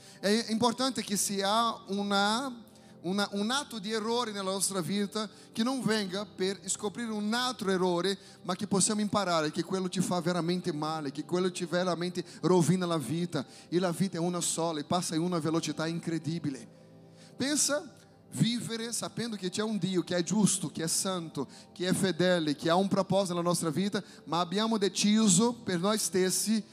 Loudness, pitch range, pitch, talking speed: -30 LUFS, 175-215 Hz, 190 Hz, 175 wpm